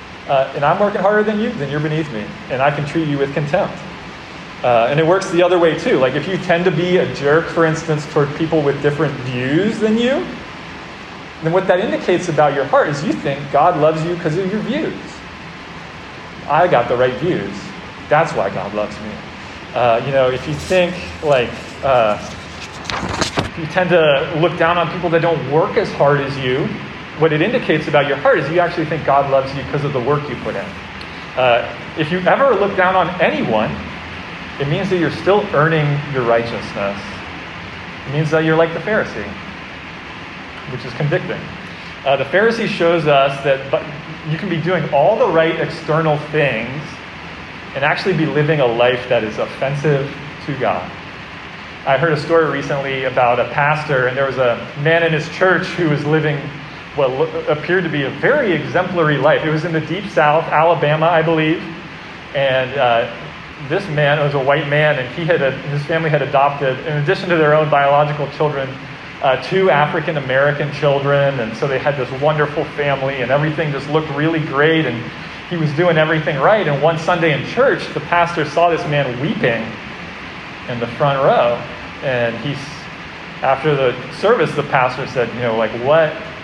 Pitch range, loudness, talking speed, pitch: 135-165 Hz, -16 LUFS, 190 wpm, 150 Hz